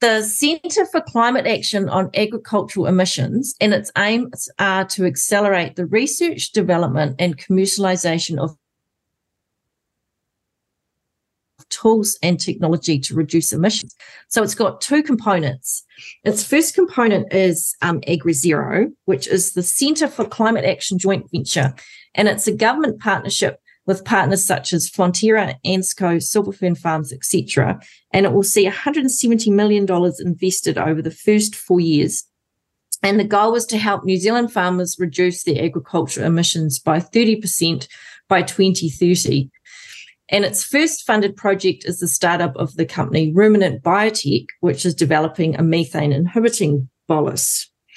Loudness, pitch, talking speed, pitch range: -18 LUFS, 185 Hz, 135 wpm, 165-210 Hz